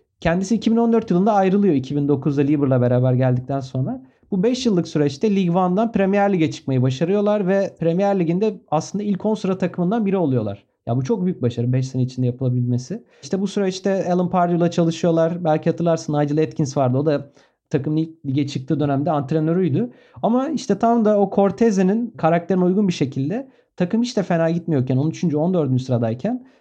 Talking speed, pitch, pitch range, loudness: 165 wpm, 170 Hz, 145-200 Hz, -20 LUFS